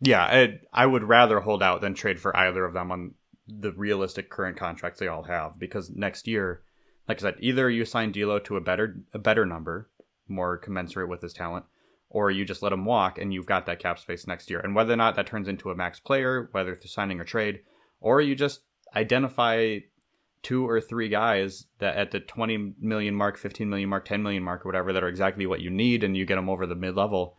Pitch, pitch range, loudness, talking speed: 100 Hz, 95-115 Hz, -26 LUFS, 230 wpm